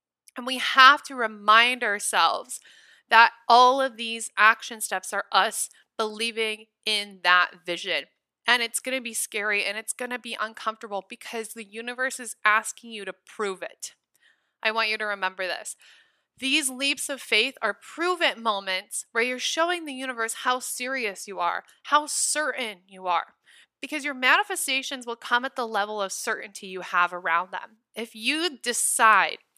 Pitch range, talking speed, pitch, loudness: 205-260 Hz, 165 wpm, 230 Hz, -24 LUFS